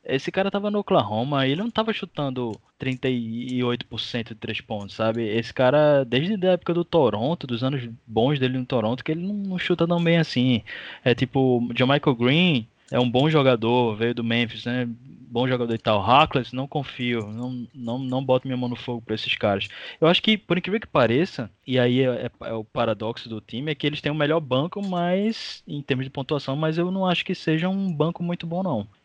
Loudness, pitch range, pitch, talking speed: -23 LUFS, 120-165 Hz, 130 Hz, 215 wpm